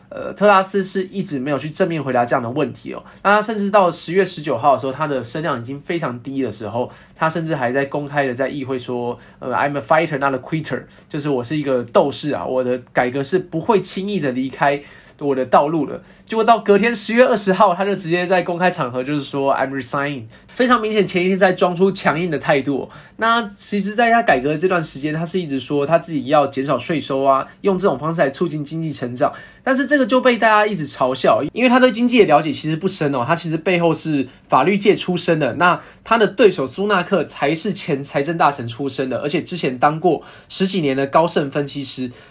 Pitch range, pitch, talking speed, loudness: 140-195 Hz, 160 Hz, 375 characters per minute, -18 LUFS